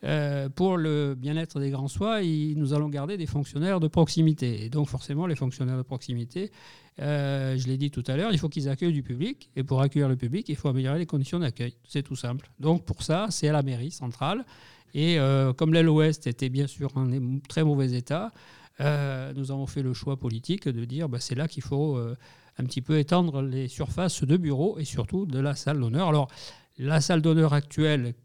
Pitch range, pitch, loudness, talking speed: 130-160 Hz, 145 Hz, -27 LUFS, 215 wpm